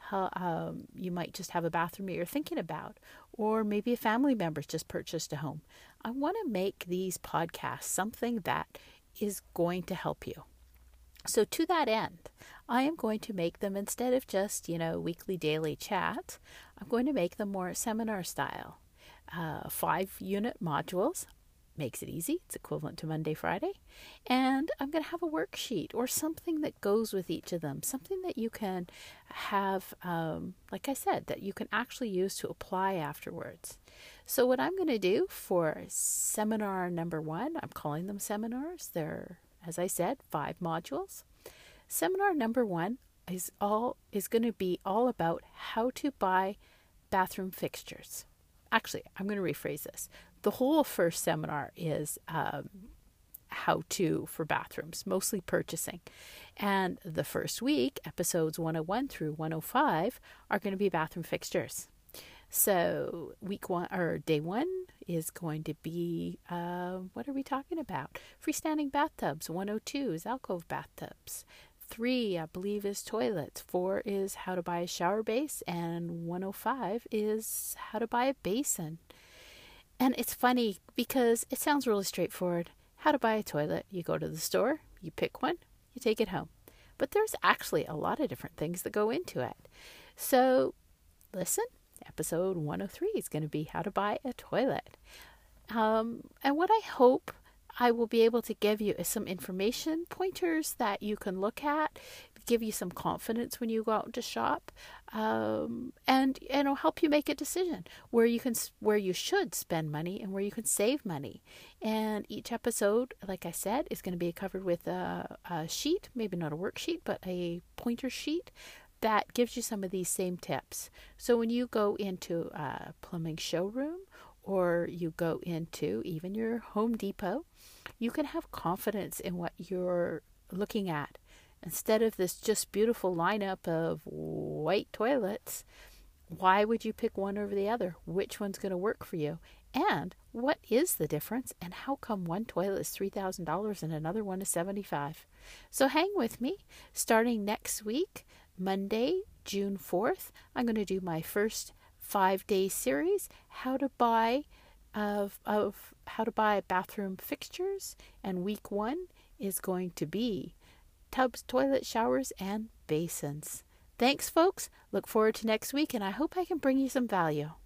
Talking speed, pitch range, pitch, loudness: 170 wpm, 180-250 Hz, 210 Hz, -33 LUFS